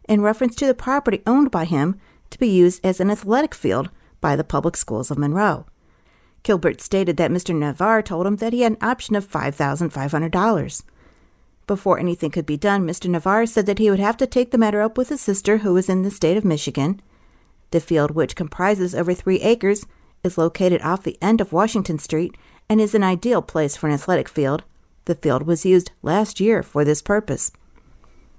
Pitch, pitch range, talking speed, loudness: 185 Hz, 165-215 Hz, 200 wpm, -20 LUFS